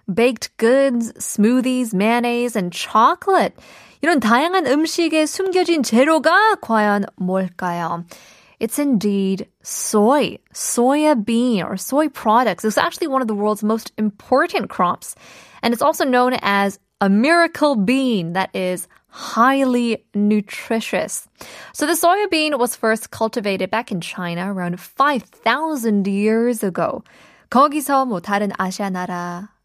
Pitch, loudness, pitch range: 230 Hz, -18 LUFS, 200-285 Hz